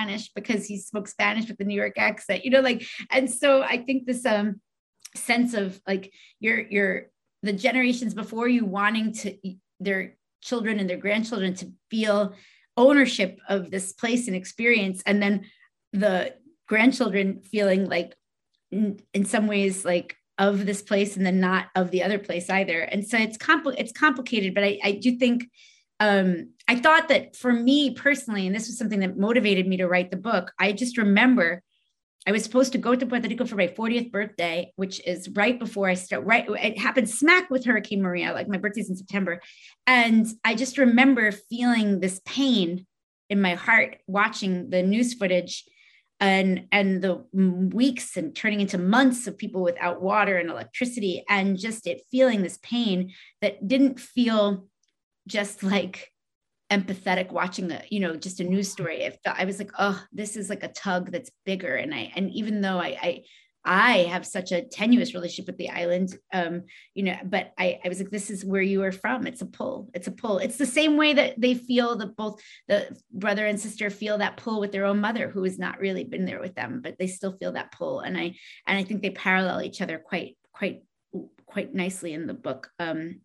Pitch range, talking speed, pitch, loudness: 190-235 Hz, 195 wpm, 205 Hz, -24 LUFS